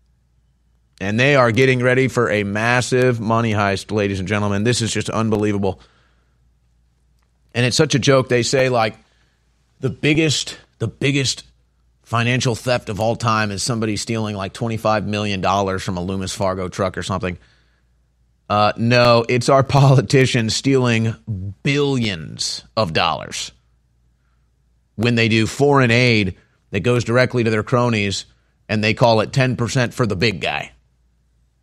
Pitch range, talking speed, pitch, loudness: 90-120 Hz, 150 wpm, 110 Hz, -18 LUFS